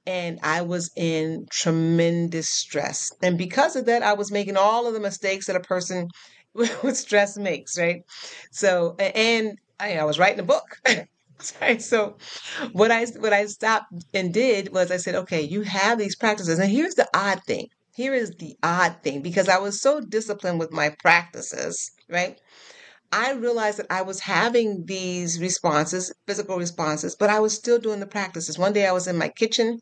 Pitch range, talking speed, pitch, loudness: 175-220 Hz, 185 wpm, 195 Hz, -23 LUFS